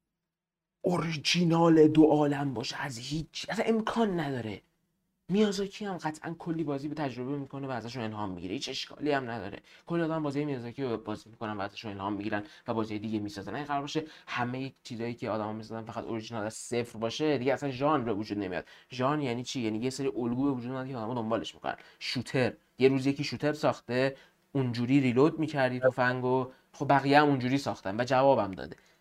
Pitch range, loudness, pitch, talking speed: 120-155 Hz, -30 LUFS, 135 Hz, 185 wpm